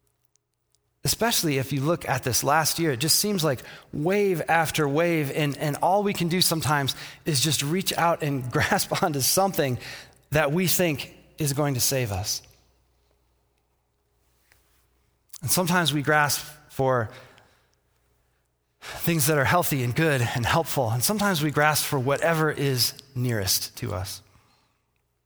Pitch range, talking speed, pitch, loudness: 120-160 Hz, 145 wpm, 145 Hz, -24 LUFS